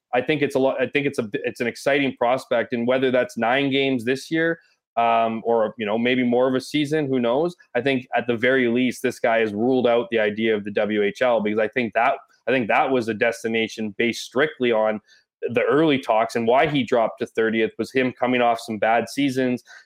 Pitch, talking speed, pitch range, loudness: 120 Hz, 230 wpm, 115-130 Hz, -21 LUFS